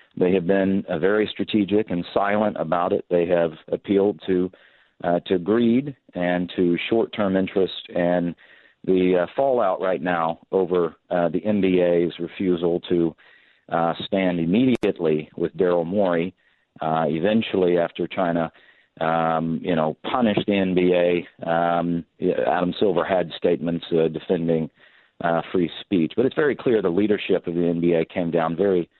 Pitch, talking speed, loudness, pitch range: 90 Hz, 145 wpm, -22 LUFS, 85-95 Hz